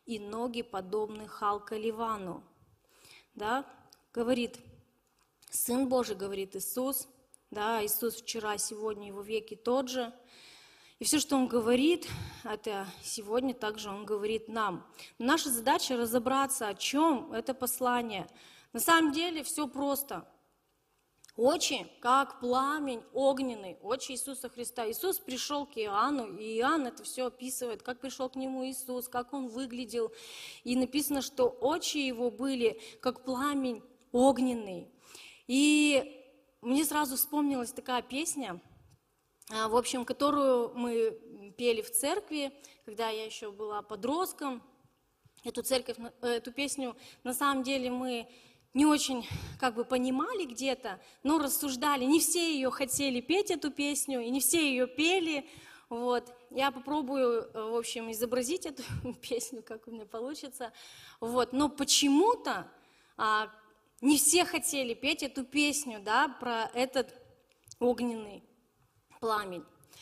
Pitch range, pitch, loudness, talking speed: 230-275 Hz, 250 Hz, -32 LUFS, 130 wpm